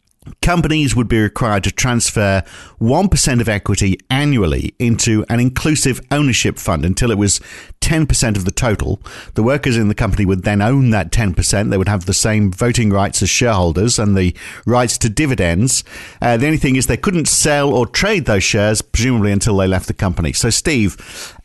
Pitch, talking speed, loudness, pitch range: 110 Hz, 185 wpm, -15 LUFS, 100-125 Hz